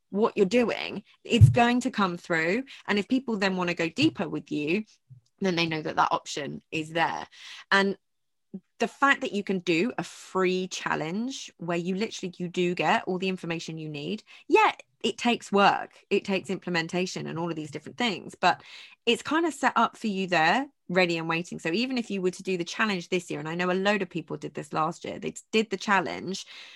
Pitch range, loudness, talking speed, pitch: 170-225 Hz, -27 LUFS, 220 wpm, 190 Hz